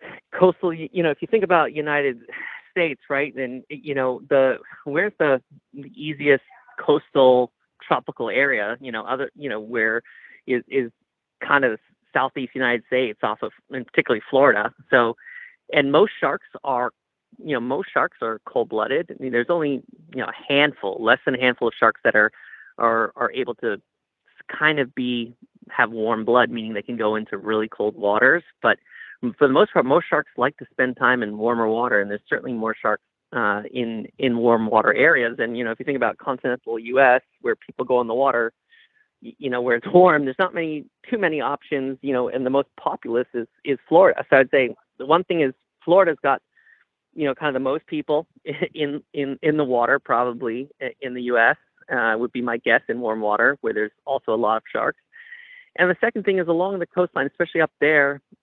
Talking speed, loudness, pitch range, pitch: 200 wpm, -21 LUFS, 120-155 Hz, 135 Hz